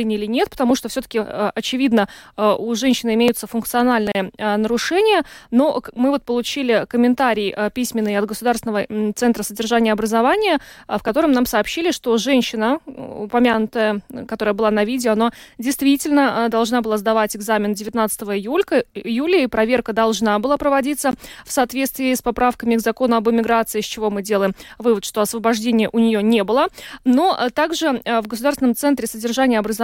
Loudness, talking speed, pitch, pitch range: -19 LUFS, 145 wpm, 230 Hz, 215-260 Hz